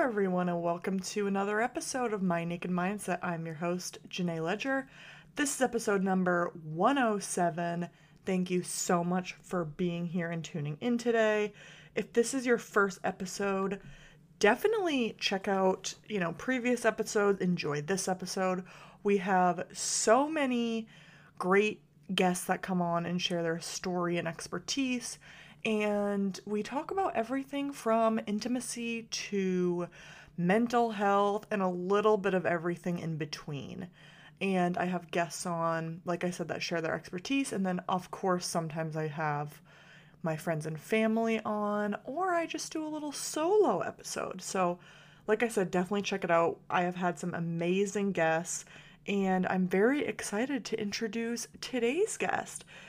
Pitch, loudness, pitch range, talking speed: 185 Hz, -32 LUFS, 170-220 Hz, 150 wpm